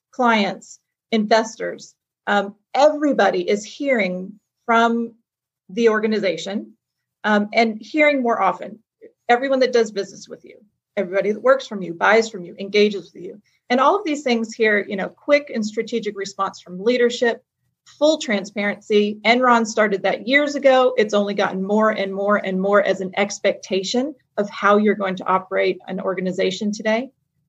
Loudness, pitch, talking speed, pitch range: -19 LUFS, 210 Hz, 155 wpm, 195-240 Hz